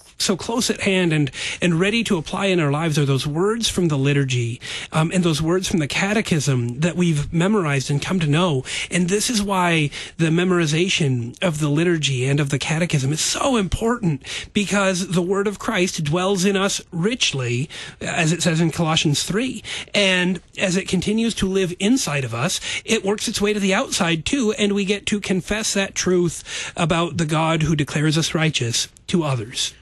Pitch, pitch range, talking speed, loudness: 175 Hz, 155-200 Hz, 195 wpm, -20 LUFS